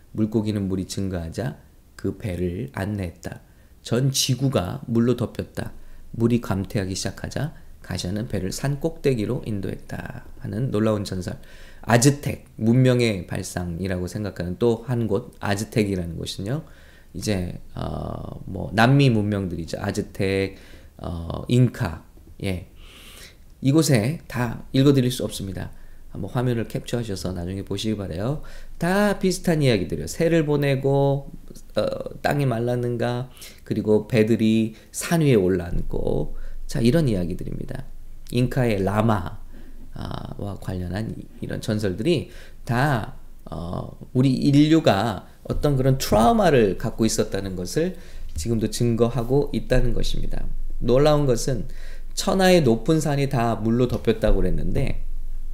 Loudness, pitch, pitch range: -23 LUFS, 110 Hz, 95-130 Hz